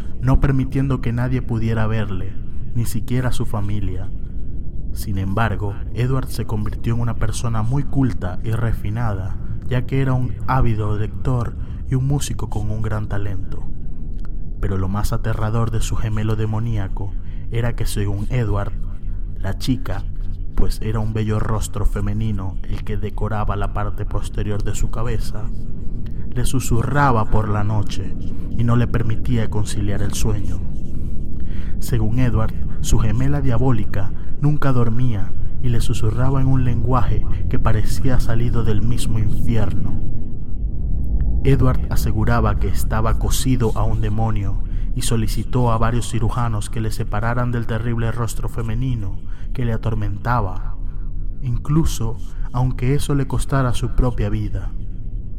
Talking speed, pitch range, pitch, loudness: 135 wpm, 100-120 Hz, 110 Hz, -22 LUFS